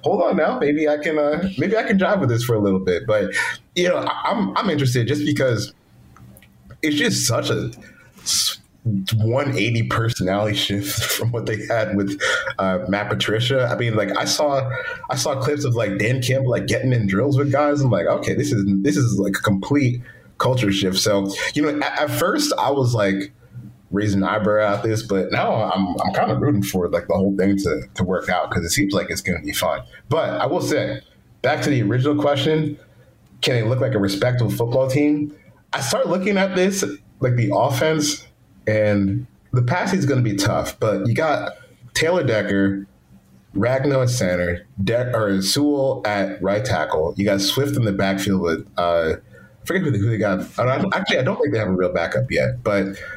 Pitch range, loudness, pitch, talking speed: 100-135 Hz, -20 LUFS, 115 Hz, 205 wpm